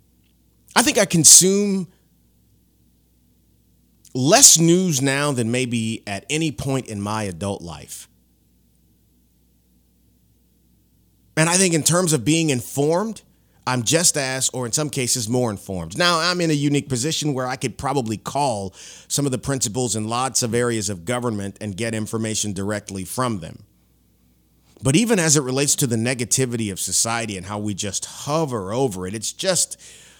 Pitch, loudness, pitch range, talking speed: 120 Hz, -19 LUFS, 95-145 Hz, 155 wpm